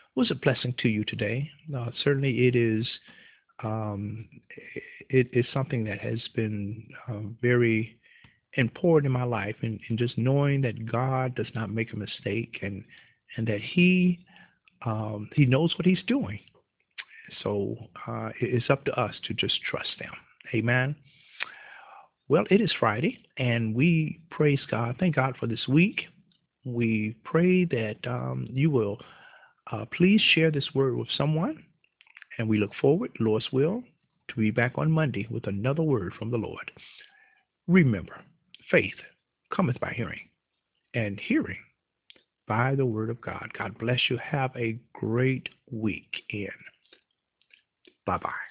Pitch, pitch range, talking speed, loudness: 125 Hz, 110-155 Hz, 150 wpm, -27 LUFS